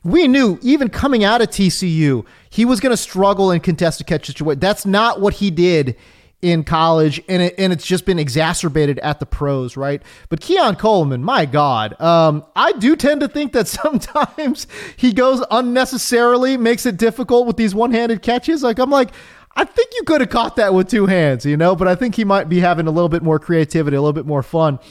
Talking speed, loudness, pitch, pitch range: 215 wpm, -16 LUFS, 190 Hz, 160-245 Hz